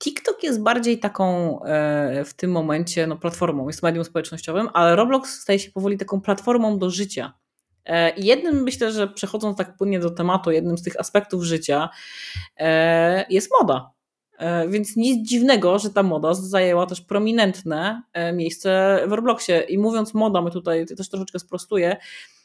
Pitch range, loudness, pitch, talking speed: 165-210 Hz, -21 LUFS, 185 Hz, 165 wpm